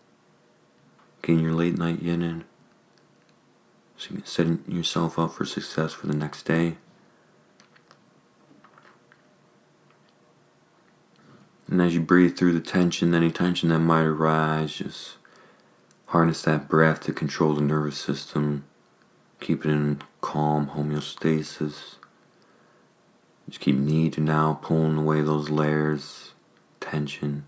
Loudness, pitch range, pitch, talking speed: -24 LUFS, 75-85 Hz, 80 Hz, 115 wpm